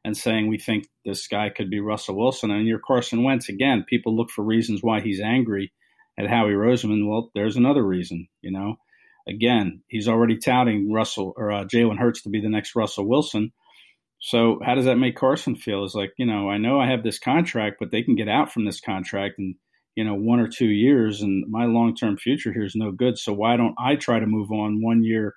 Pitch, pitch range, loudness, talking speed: 110 Hz, 105-115 Hz, -22 LUFS, 225 wpm